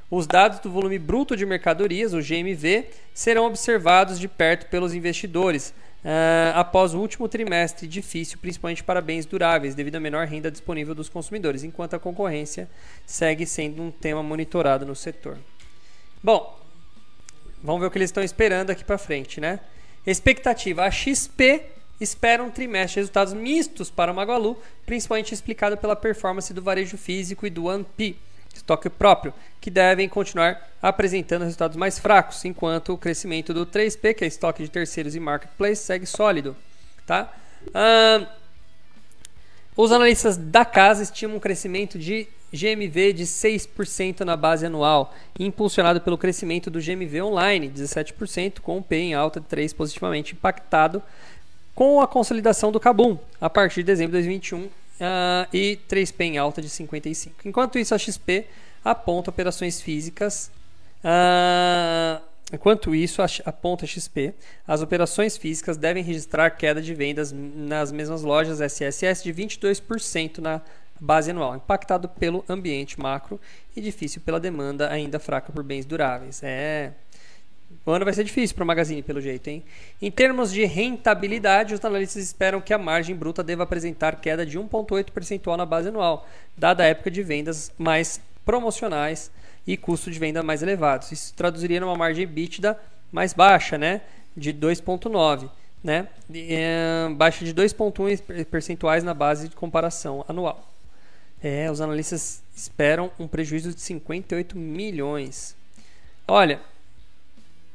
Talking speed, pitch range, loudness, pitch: 150 wpm, 155-200 Hz, -23 LUFS, 175 Hz